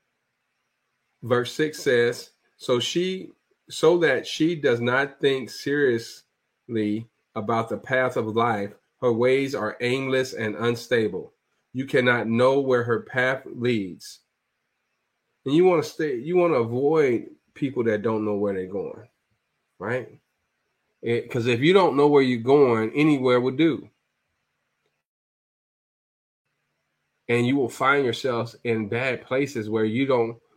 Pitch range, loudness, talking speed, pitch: 115-140 Hz, -23 LUFS, 135 wpm, 125 Hz